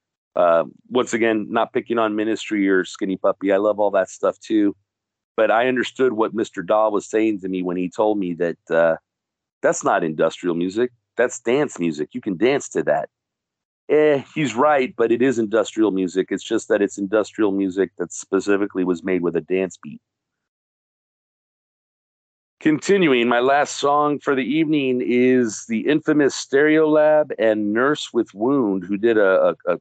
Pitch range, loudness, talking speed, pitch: 95-130 Hz, -20 LUFS, 175 wpm, 110 Hz